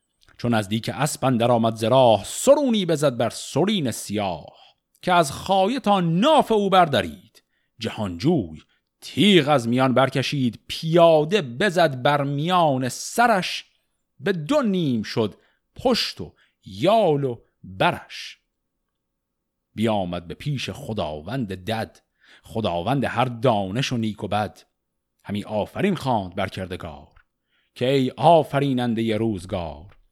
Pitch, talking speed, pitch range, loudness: 130 Hz, 120 wpm, 110-165 Hz, -22 LUFS